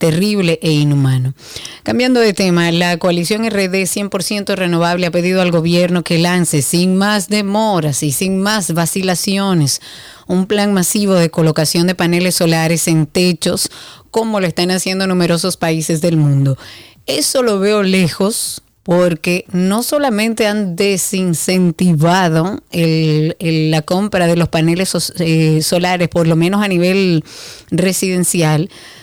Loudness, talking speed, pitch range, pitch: -14 LUFS, 140 wpm, 165-195 Hz, 180 Hz